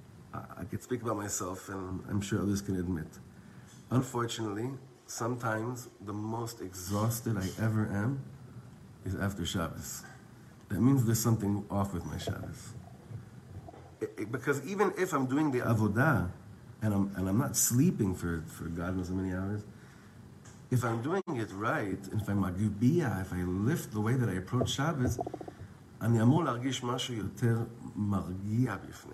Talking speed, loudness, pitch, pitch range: 145 wpm, -33 LUFS, 110 Hz, 100-125 Hz